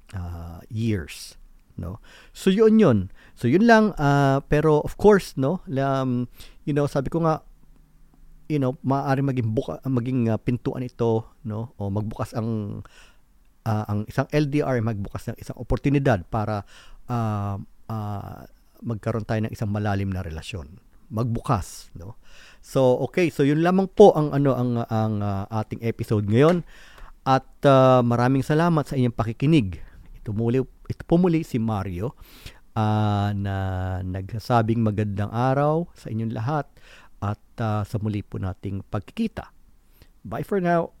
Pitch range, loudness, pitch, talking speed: 105-140 Hz, -23 LUFS, 115 Hz, 145 wpm